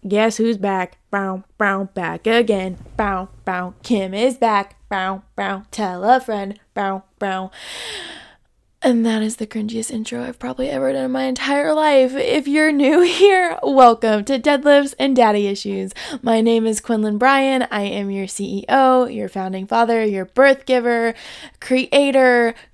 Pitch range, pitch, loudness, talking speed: 200-260 Hz, 225 Hz, -18 LUFS, 155 wpm